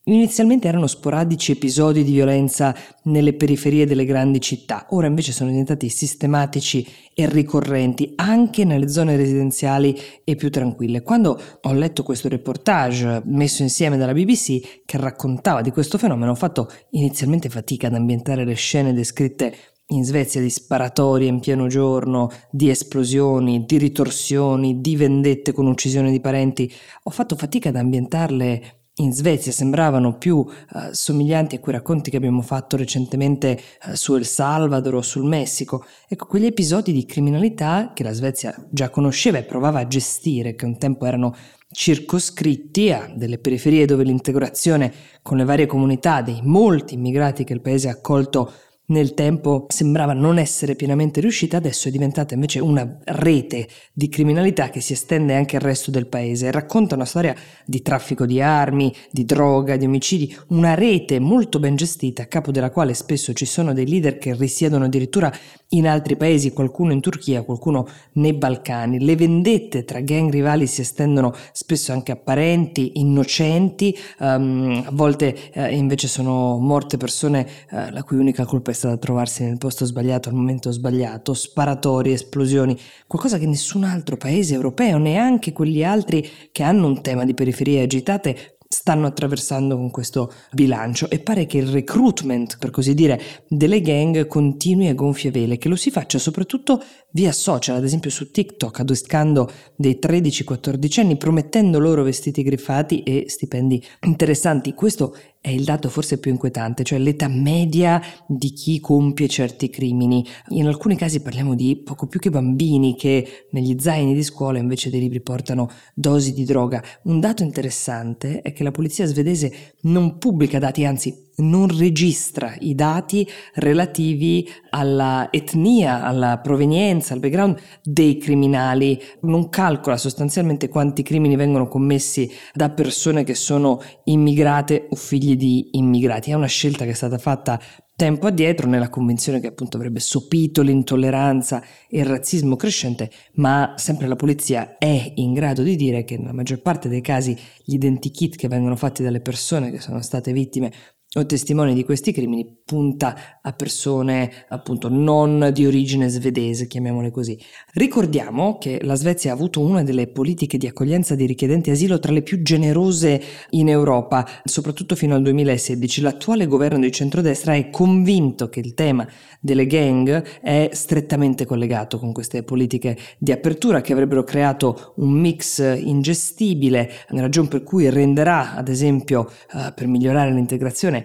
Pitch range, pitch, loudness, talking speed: 130-155 Hz, 140 Hz, -19 LUFS, 160 wpm